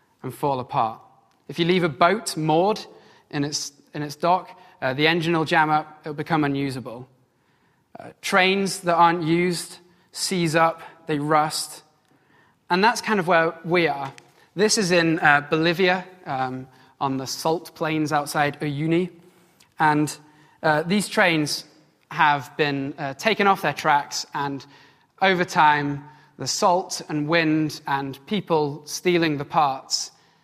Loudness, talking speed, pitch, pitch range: -22 LUFS, 150 wpm, 155 Hz, 145-175 Hz